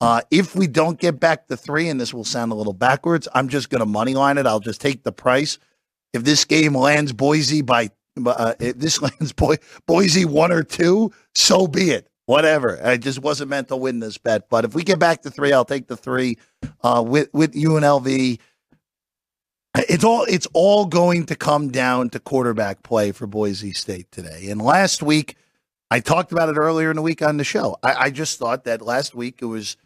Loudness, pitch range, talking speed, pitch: -19 LUFS, 120-160 Hz, 210 wpm, 140 Hz